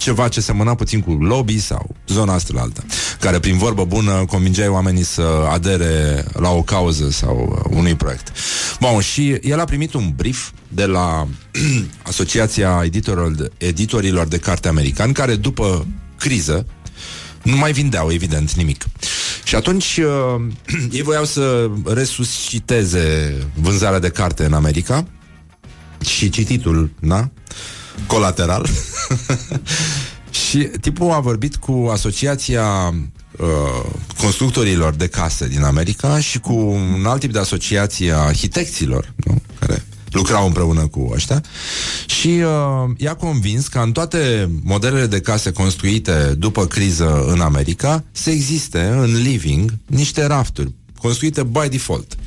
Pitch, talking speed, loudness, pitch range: 105 Hz, 125 wpm, -17 LUFS, 85-125 Hz